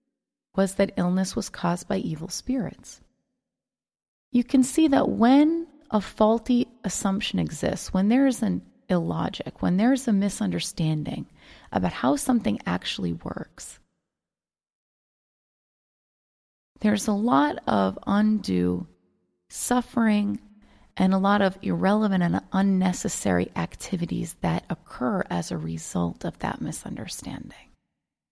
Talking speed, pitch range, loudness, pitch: 110 wpm, 180-245 Hz, -25 LUFS, 205 Hz